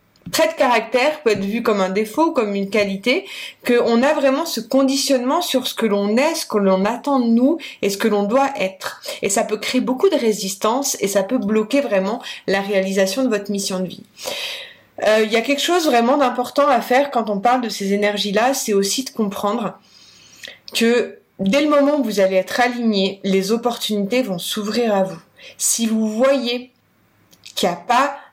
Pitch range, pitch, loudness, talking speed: 205-265 Hz, 230 Hz, -18 LUFS, 200 wpm